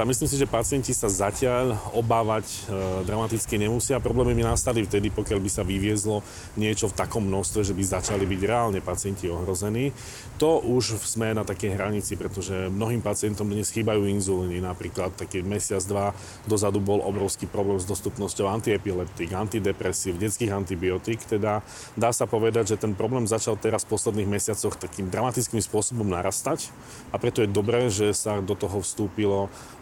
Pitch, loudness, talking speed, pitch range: 105 Hz, -26 LUFS, 160 wpm, 100-115 Hz